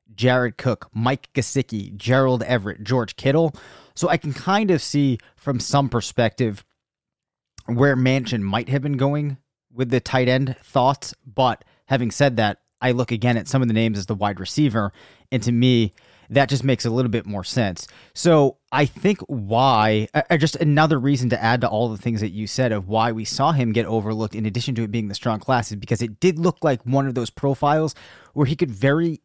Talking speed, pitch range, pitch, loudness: 210 wpm, 110-140 Hz, 125 Hz, -21 LUFS